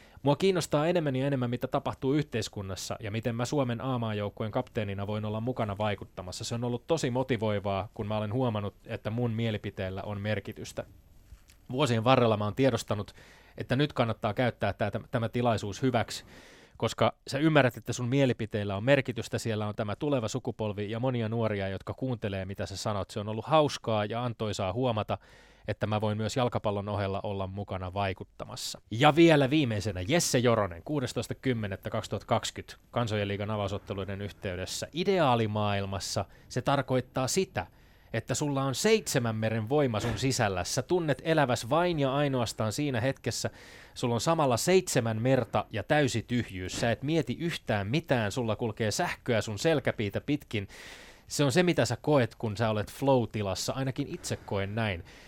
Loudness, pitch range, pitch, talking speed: -30 LUFS, 105-130 Hz, 115 Hz, 155 wpm